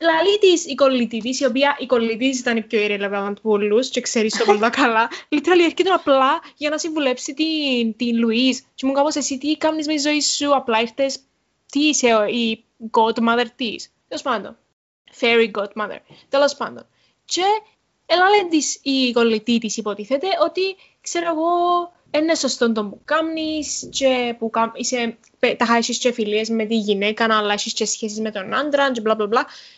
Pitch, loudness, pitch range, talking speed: 255 Hz, -19 LUFS, 225-300 Hz, 170 wpm